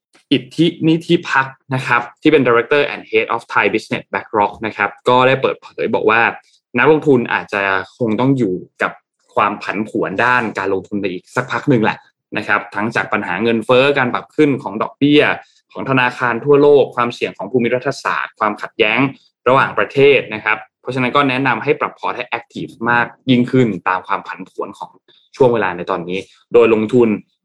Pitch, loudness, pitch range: 120 Hz, -16 LUFS, 105-135 Hz